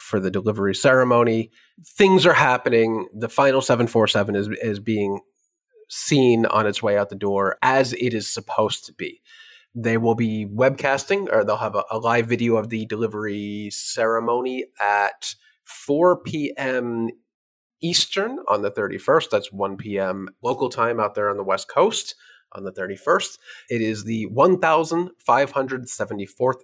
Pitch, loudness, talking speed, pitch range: 120 Hz, -21 LUFS, 150 wpm, 110-140 Hz